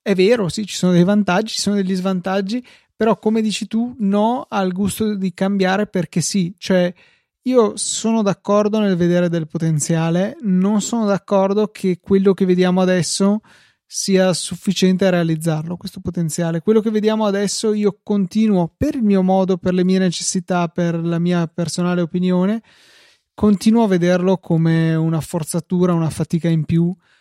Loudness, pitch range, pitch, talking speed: -18 LUFS, 175-205 Hz, 190 Hz, 160 wpm